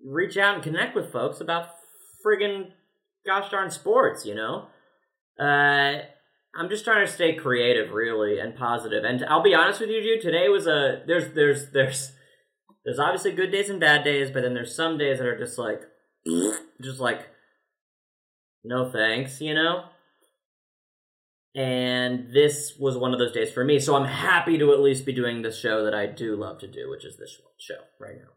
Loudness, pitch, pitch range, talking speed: -24 LUFS, 145 Hz, 130-195 Hz, 190 wpm